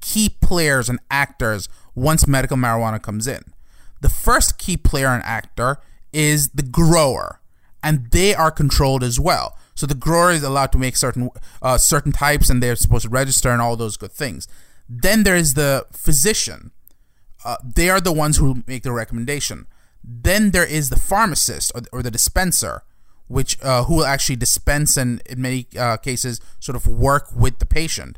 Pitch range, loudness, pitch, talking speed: 120-150 Hz, -18 LUFS, 130 Hz, 185 wpm